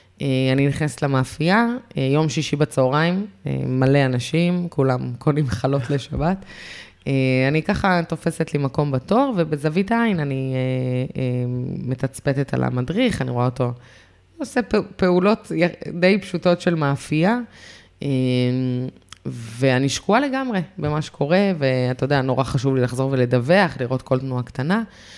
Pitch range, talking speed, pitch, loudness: 130-175 Hz, 135 wpm, 140 Hz, -21 LUFS